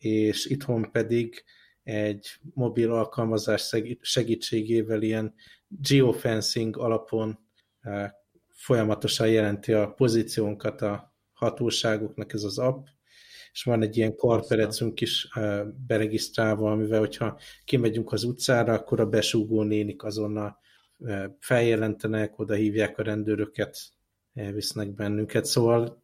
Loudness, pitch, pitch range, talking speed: -26 LUFS, 110 Hz, 105-115 Hz, 100 wpm